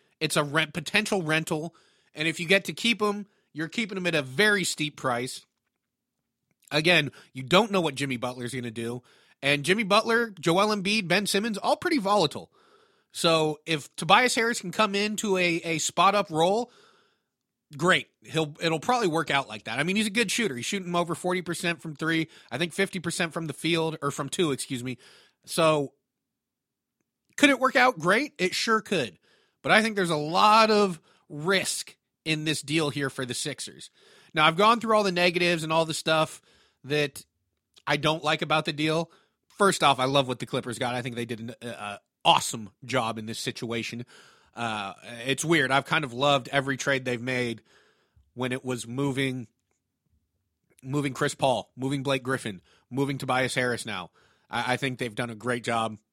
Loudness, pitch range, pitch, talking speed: -26 LUFS, 130-185 Hz, 155 Hz, 190 wpm